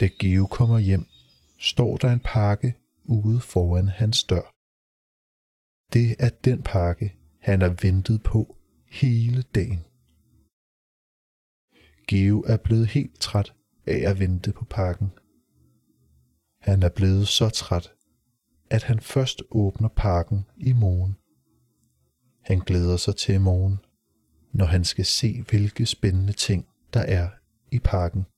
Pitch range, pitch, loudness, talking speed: 90-115 Hz, 100 Hz, -23 LUFS, 125 wpm